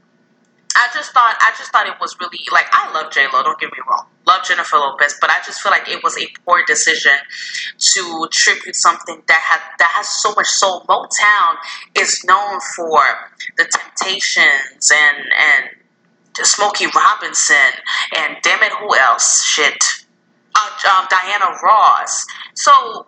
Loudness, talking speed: -13 LUFS, 160 wpm